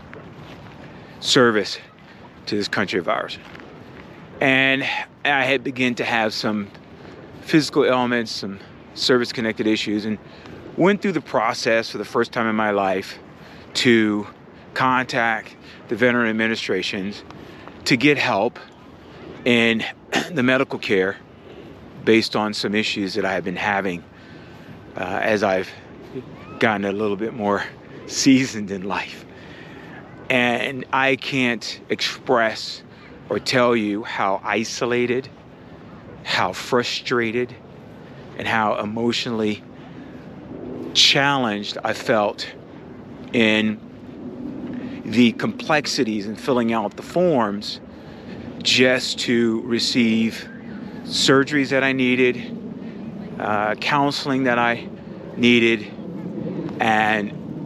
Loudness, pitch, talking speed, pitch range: -20 LUFS, 120 Hz, 105 wpm, 110-135 Hz